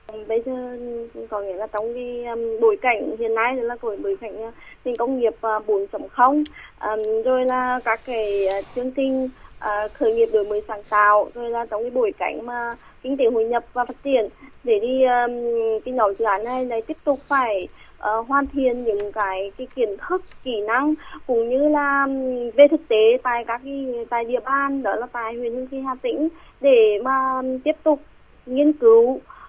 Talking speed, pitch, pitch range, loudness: 205 wpm, 245 Hz, 225-275 Hz, -21 LUFS